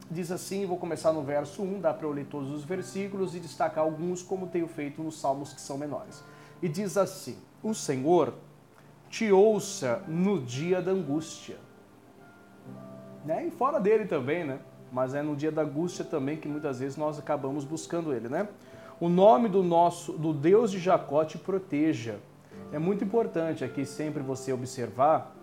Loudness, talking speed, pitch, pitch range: -29 LUFS, 170 wpm, 160 Hz, 145-190 Hz